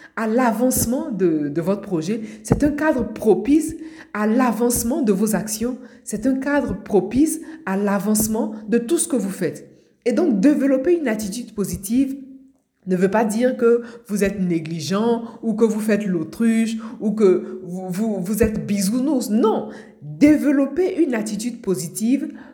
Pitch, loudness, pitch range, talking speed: 230 Hz, -20 LUFS, 205-260 Hz, 155 wpm